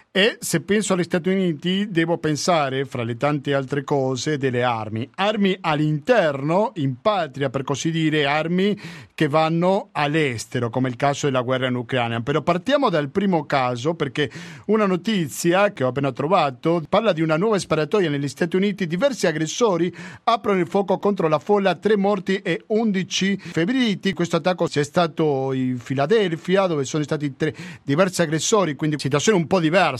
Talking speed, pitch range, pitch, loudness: 170 wpm, 145-190 Hz, 165 Hz, -21 LUFS